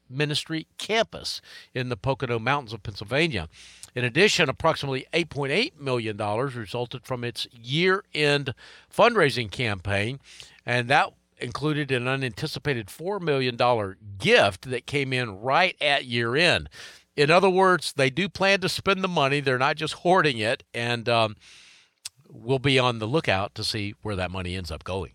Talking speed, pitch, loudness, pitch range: 155 wpm, 130 Hz, -24 LUFS, 115-155 Hz